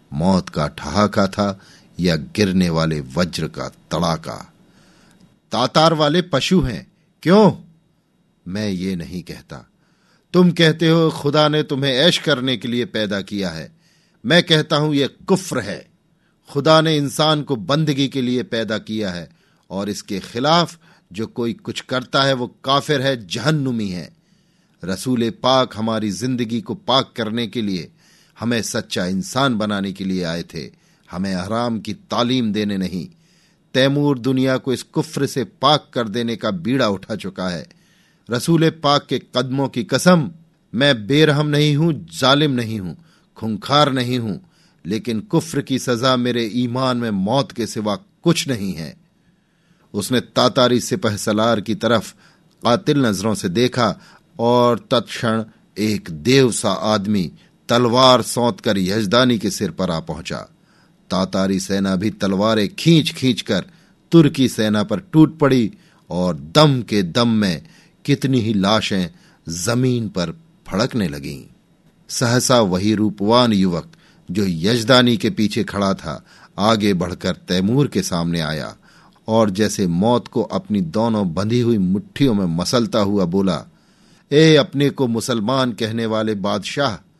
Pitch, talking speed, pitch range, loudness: 120 Hz, 145 wpm, 105-150 Hz, -18 LUFS